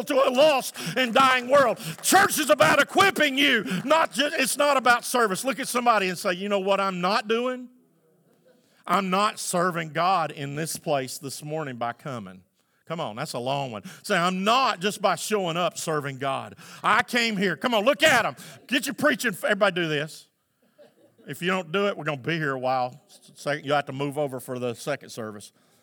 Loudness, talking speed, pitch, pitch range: -24 LUFS, 205 wpm, 190 Hz, 150-250 Hz